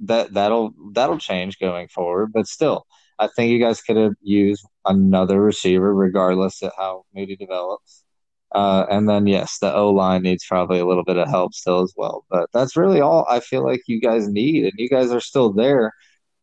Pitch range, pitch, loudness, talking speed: 95-105 Hz, 100 Hz, -19 LUFS, 200 wpm